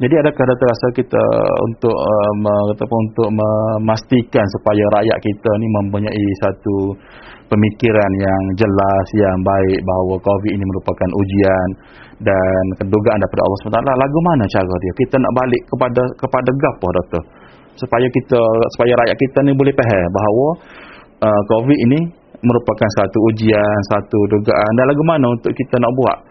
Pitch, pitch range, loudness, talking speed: 110 Hz, 100-125 Hz, -15 LUFS, 155 wpm